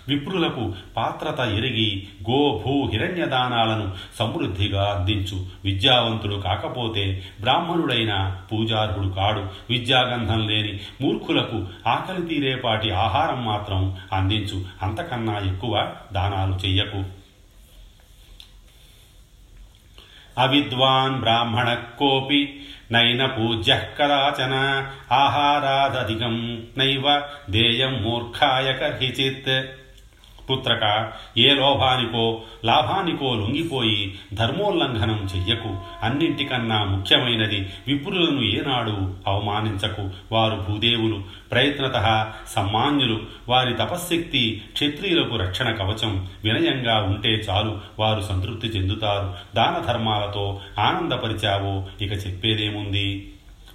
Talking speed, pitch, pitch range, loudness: 70 wpm, 110 Hz, 100-130 Hz, -22 LUFS